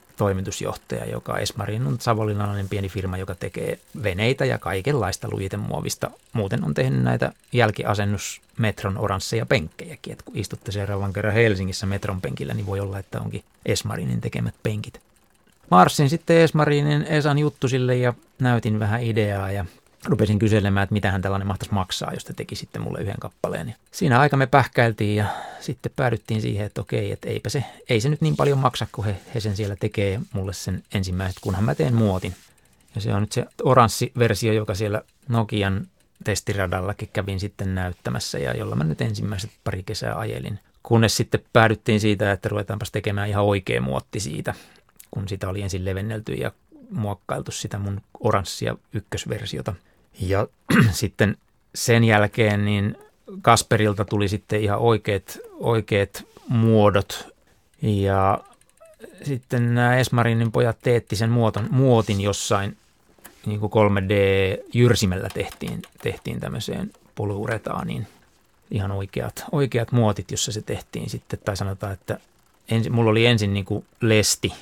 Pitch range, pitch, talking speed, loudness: 100-115 Hz, 105 Hz, 150 wpm, -23 LUFS